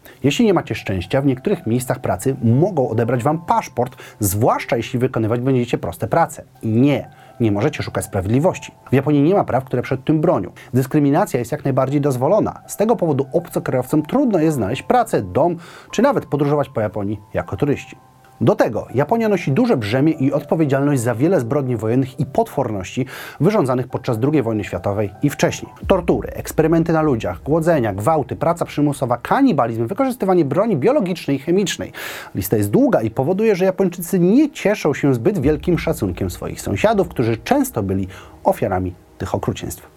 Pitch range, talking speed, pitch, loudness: 120-165 Hz, 165 wpm, 135 Hz, -19 LUFS